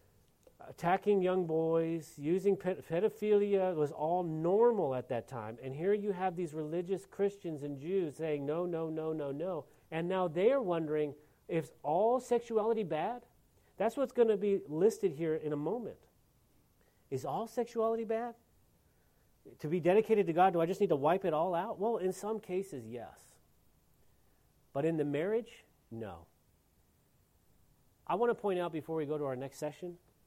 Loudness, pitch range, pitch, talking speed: -34 LUFS, 150-205 Hz, 175 Hz, 170 wpm